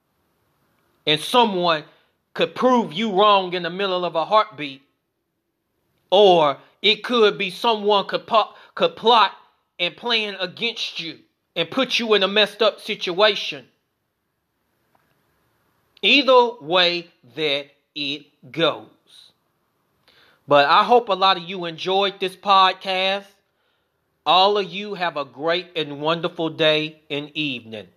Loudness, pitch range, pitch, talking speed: -19 LUFS, 160-210 Hz, 185 Hz, 125 wpm